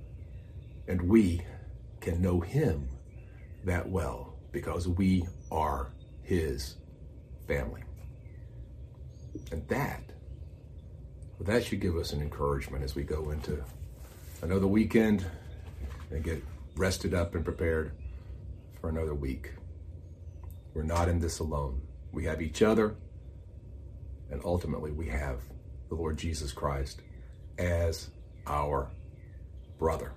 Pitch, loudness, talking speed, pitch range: 85 Hz, -32 LUFS, 110 wpm, 75-90 Hz